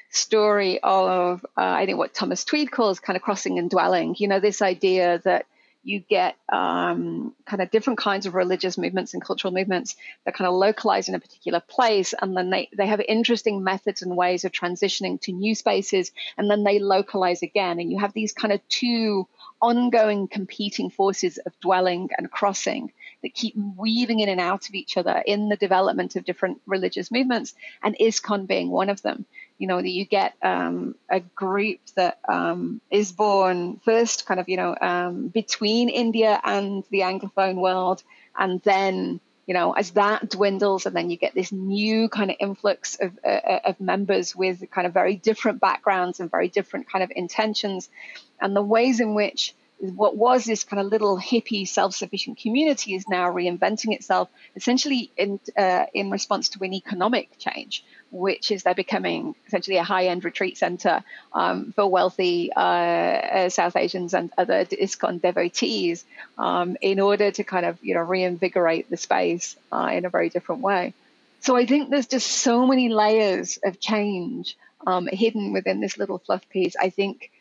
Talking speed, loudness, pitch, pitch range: 180 wpm, -23 LUFS, 200 Hz, 185-220 Hz